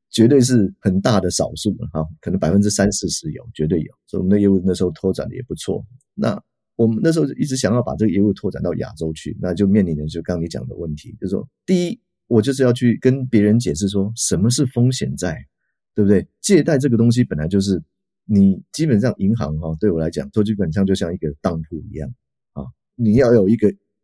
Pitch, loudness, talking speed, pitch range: 100 Hz, -19 LUFS, 340 characters per minute, 90-115 Hz